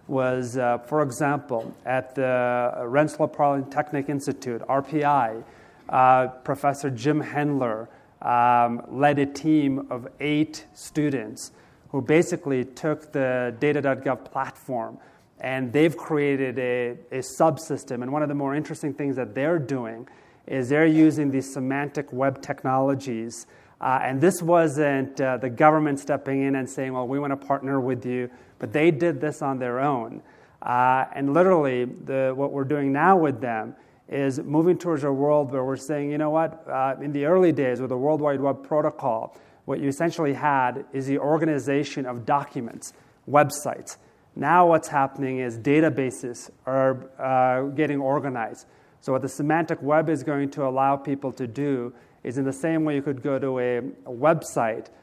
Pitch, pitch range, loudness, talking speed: 140 Hz, 130-150 Hz, -24 LUFS, 165 wpm